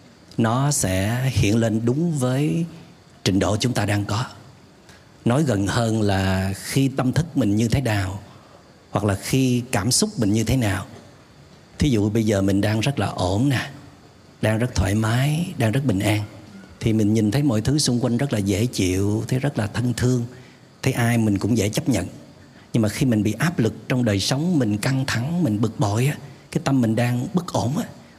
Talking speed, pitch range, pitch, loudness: 210 wpm, 105-130 Hz, 115 Hz, -22 LUFS